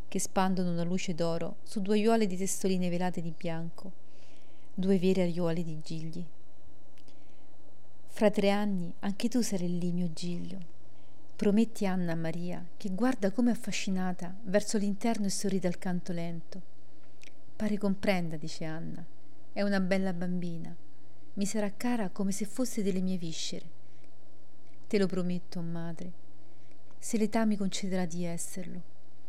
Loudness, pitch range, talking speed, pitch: -32 LUFS, 175-205 Hz, 140 wpm, 185 Hz